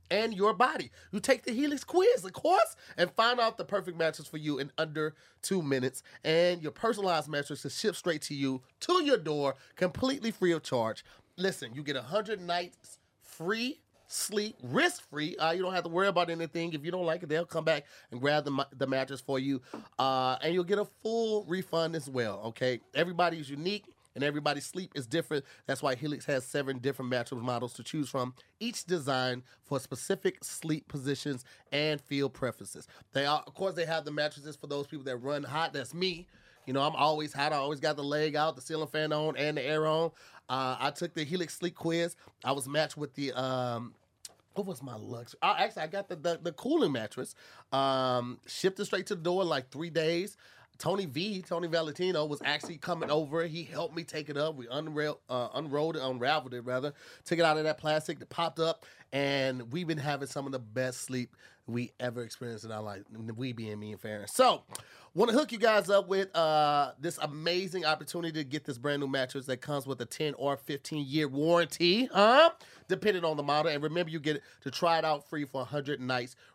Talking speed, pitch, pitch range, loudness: 215 wpm, 155 Hz, 135-175 Hz, -32 LUFS